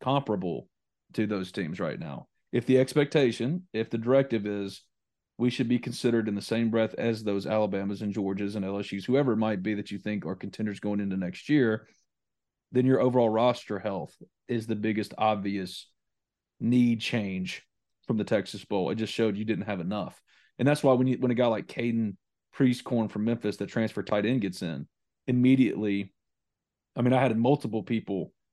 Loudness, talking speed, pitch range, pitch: -28 LUFS, 185 wpm, 100-125 Hz, 110 Hz